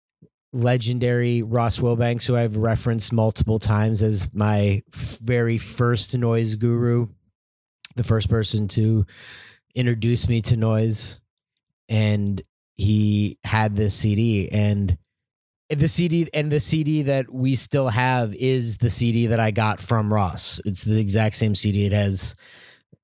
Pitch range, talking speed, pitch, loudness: 105-120 Hz, 140 wpm, 110 Hz, -22 LUFS